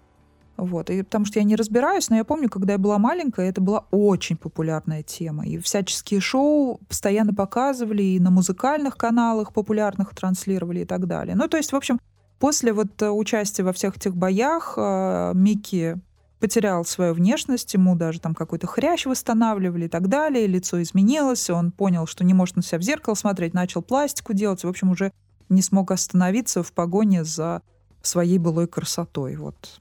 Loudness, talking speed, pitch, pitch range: -22 LUFS, 185 wpm, 195 Hz, 170-220 Hz